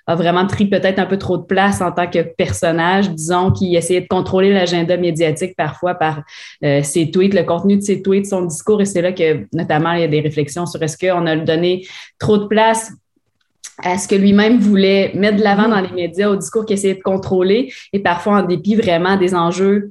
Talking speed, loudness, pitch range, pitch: 225 wpm, -15 LUFS, 170-195 Hz, 180 Hz